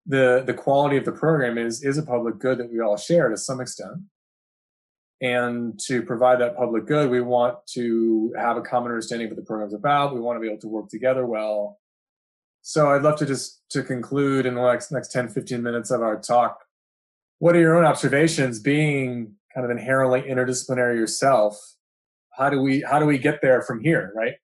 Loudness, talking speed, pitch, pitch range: -22 LUFS, 205 wpm, 125 Hz, 115-140 Hz